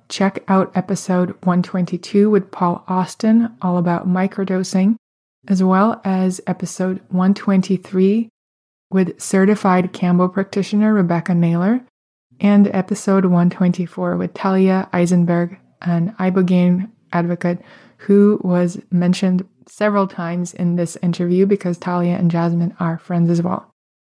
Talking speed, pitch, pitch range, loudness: 115 wpm, 185 Hz, 175-195 Hz, -17 LUFS